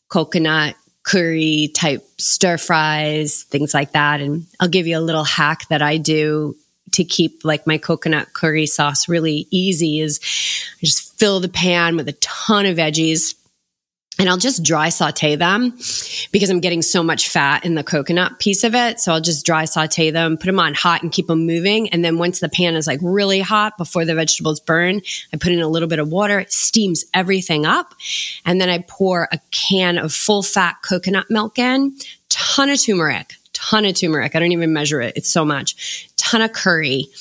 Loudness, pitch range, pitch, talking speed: -16 LUFS, 155-190 Hz, 170 Hz, 200 wpm